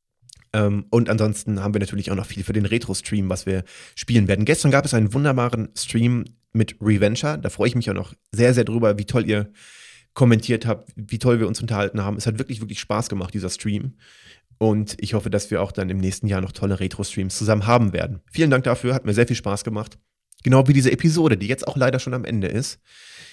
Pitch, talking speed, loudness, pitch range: 110 Hz, 225 wpm, -21 LUFS, 100-120 Hz